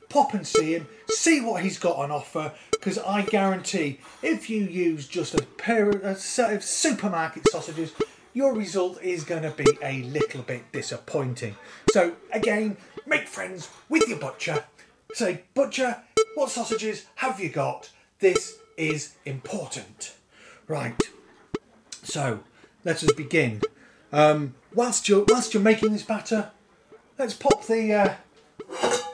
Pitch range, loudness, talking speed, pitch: 160-225 Hz, -25 LUFS, 140 wpm, 200 Hz